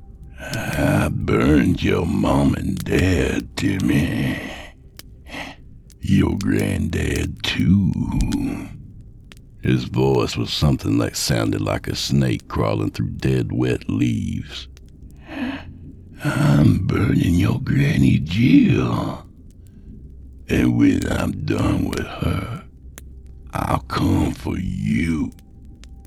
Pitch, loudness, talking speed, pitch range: 70 Hz, -20 LUFS, 95 wpm, 65-95 Hz